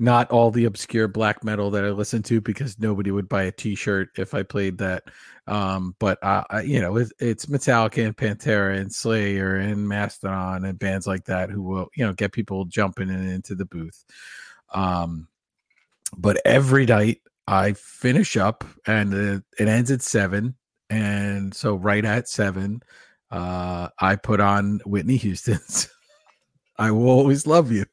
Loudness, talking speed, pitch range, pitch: -22 LUFS, 170 wpm, 95-115 Hz, 105 Hz